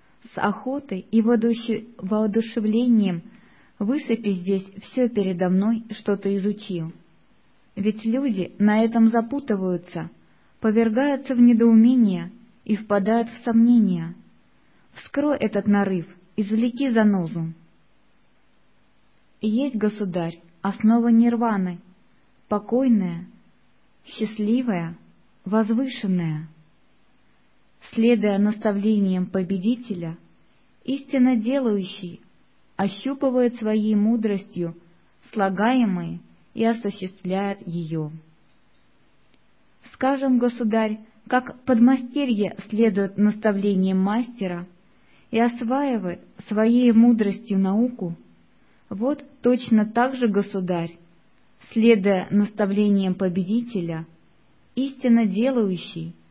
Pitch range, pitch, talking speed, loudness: 190-235 Hz, 215 Hz, 75 wpm, -22 LUFS